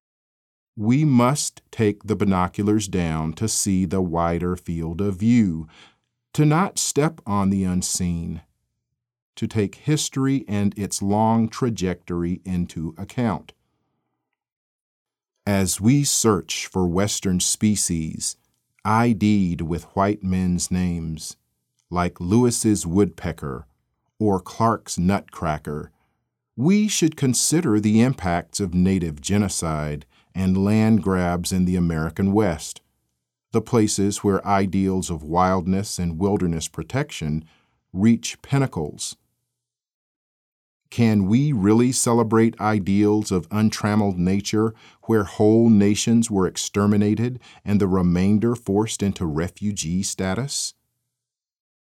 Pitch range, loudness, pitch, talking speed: 90-115 Hz, -21 LUFS, 100 Hz, 105 wpm